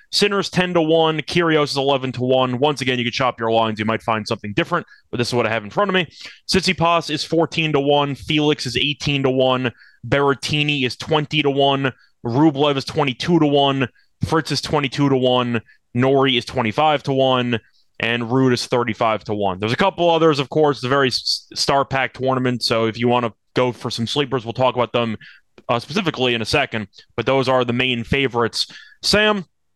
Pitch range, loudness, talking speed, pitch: 120-150 Hz, -19 LUFS, 210 wpm, 135 Hz